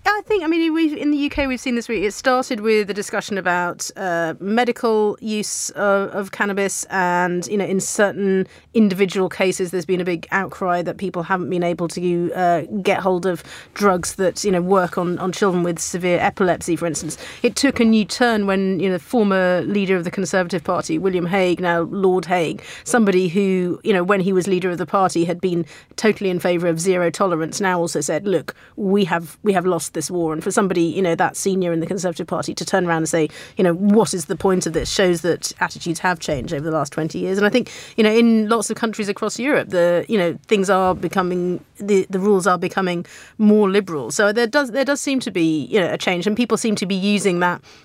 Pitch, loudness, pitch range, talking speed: 190 Hz, -19 LUFS, 175-205 Hz, 235 wpm